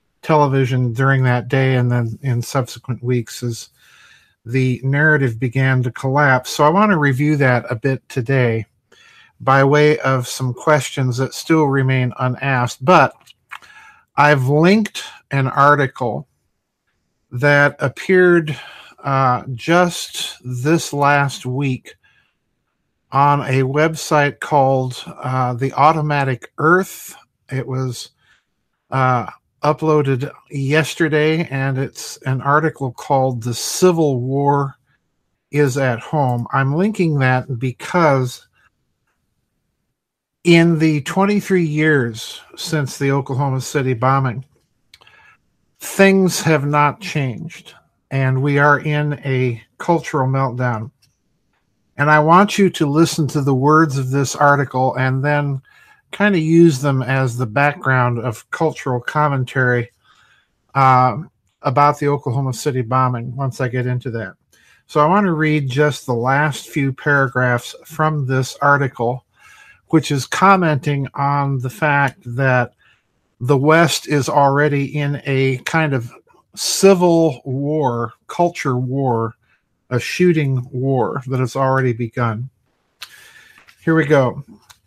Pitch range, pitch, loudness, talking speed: 130-150 Hz, 135 Hz, -17 LUFS, 120 wpm